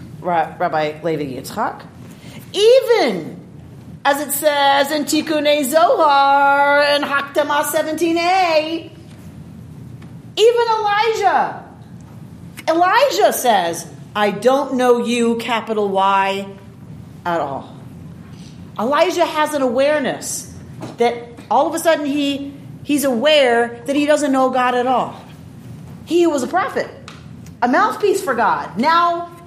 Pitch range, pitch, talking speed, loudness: 235-320 Hz, 280 Hz, 110 wpm, -16 LUFS